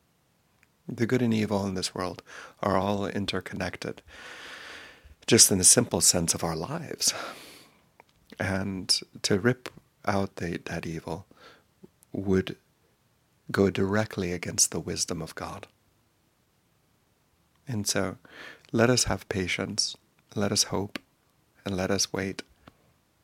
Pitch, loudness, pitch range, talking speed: 95 Hz, -26 LUFS, 90-105 Hz, 120 wpm